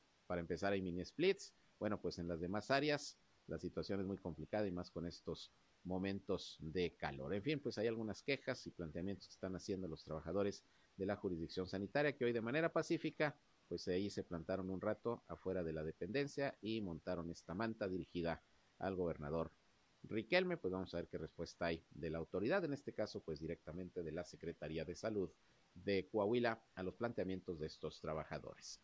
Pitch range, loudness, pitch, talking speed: 85-110 Hz, -44 LUFS, 95 Hz, 190 wpm